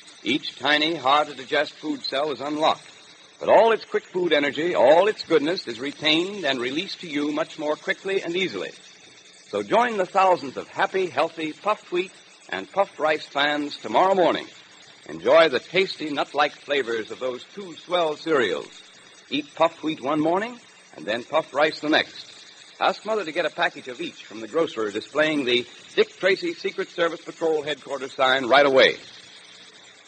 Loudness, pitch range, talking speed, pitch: -23 LUFS, 145-200 Hz, 175 wpm, 160 Hz